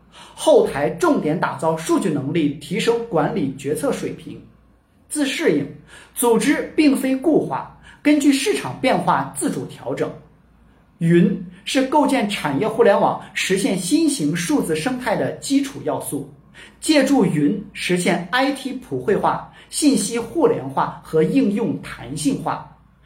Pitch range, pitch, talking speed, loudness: 170-275 Hz, 230 Hz, 210 characters per minute, -20 LUFS